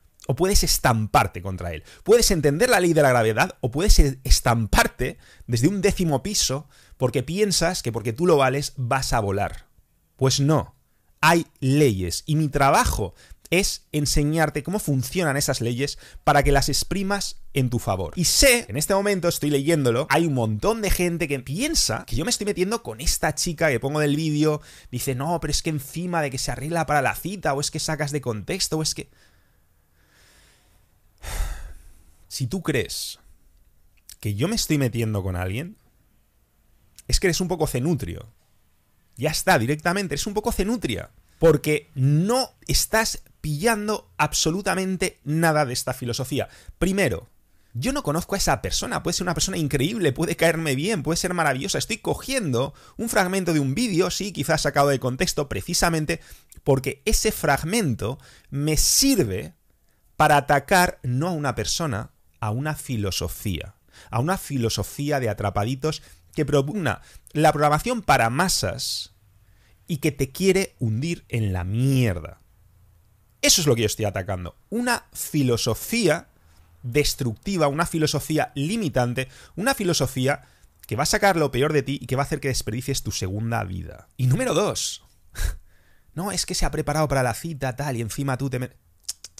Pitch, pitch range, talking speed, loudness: 140 Hz, 115-165 Hz, 165 wpm, -23 LUFS